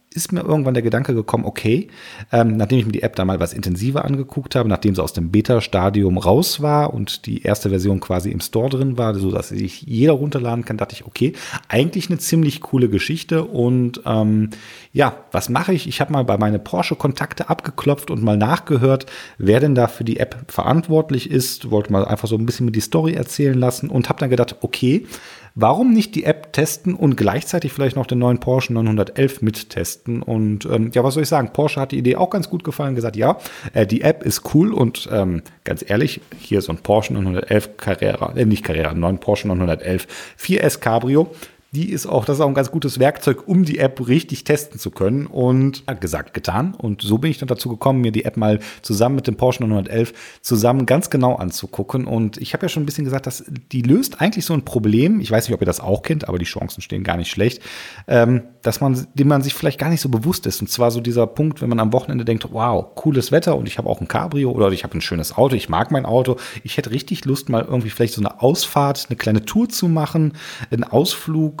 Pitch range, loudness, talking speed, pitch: 110-145 Hz, -19 LUFS, 230 wpm, 125 Hz